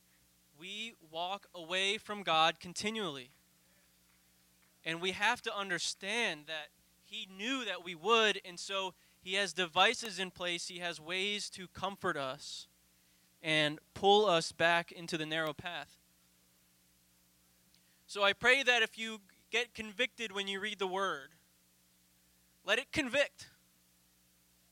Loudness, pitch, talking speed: -34 LUFS, 175 Hz, 130 wpm